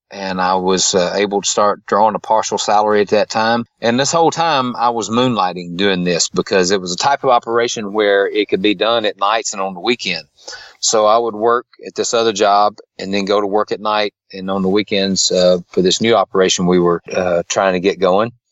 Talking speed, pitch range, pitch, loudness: 235 wpm, 95-115 Hz, 105 Hz, -15 LUFS